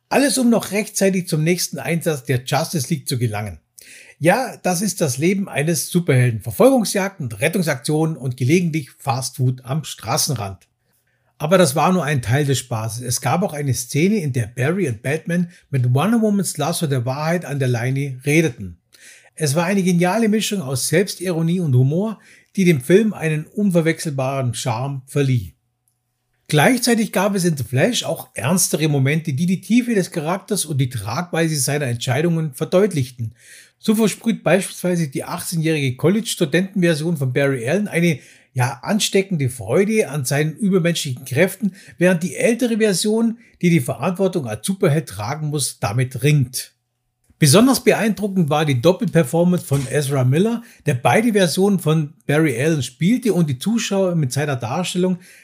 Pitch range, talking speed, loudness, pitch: 135-185 Hz, 155 wpm, -19 LUFS, 160 Hz